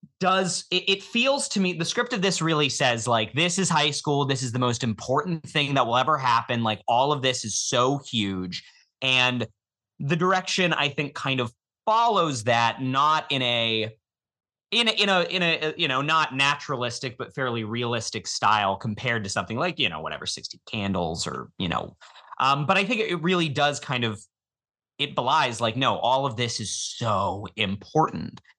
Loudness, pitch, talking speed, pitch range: -24 LUFS, 130 Hz, 190 wpm, 115-165 Hz